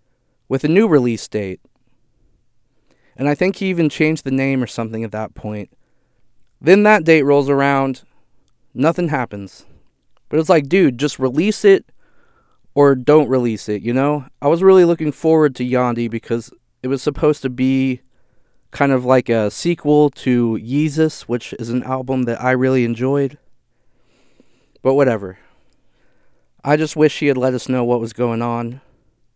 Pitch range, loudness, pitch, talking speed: 120-150 Hz, -16 LUFS, 130 Hz, 165 wpm